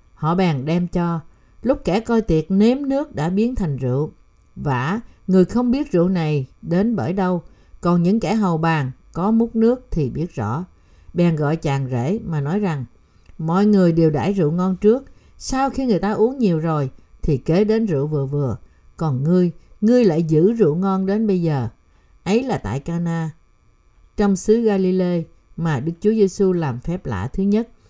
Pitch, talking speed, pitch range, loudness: 175 Hz, 185 wpm, 155-205 Hz, -20 LUFS